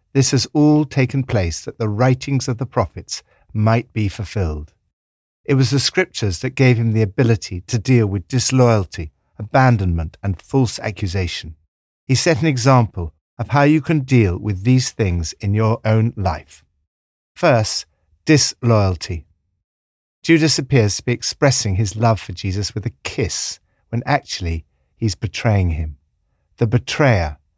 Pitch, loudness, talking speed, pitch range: 110 Hz, -18 LUFS, 150 wpm, 85-130 Hz